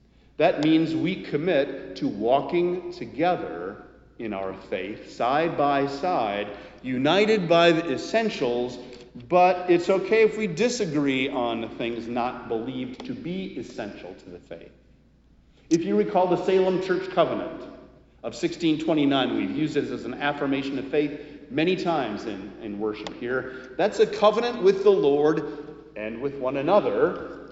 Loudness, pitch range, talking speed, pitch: -24 LUFS, 120-180 Hz, 145 wpm, 145 Hz